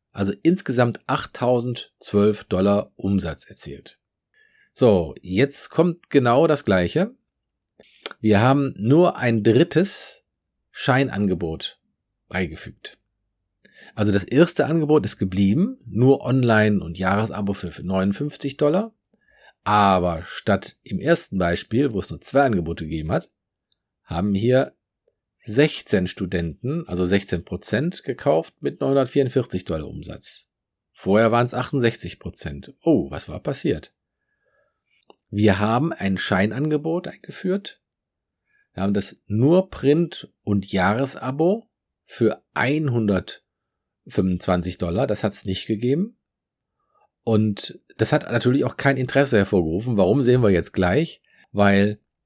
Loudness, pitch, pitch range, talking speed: -21 LUFS, 115 Hz, 100-140 Hz, 115 wpm